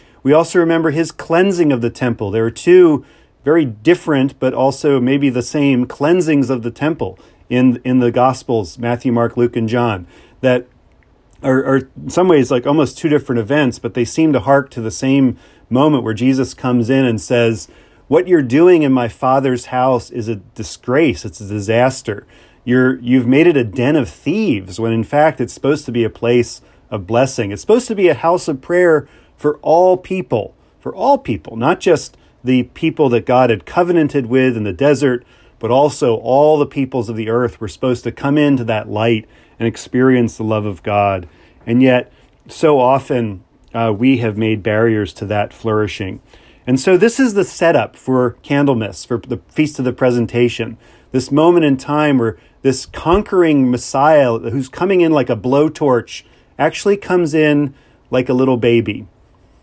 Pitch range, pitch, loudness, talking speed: 115-145 Hz, 125 Hz, -15 LUFS, 185 wpm